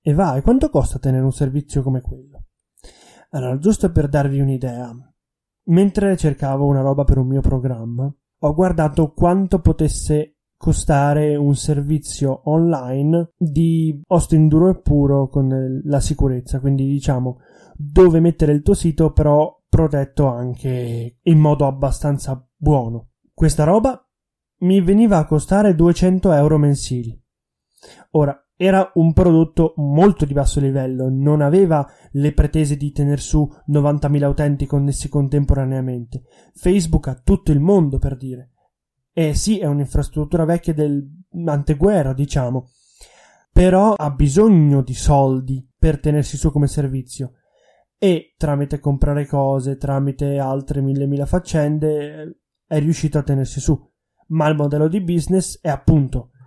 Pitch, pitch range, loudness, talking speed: 145 Hz, 135-160 Hz, -17 LUFS, 135 wpm